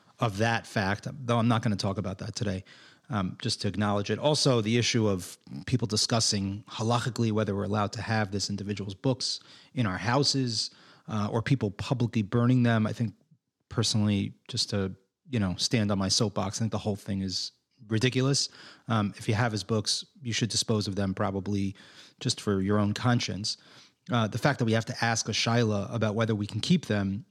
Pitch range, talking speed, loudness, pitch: 100-120 Hz, 200 wpm, -28 LUFS, 110 Hz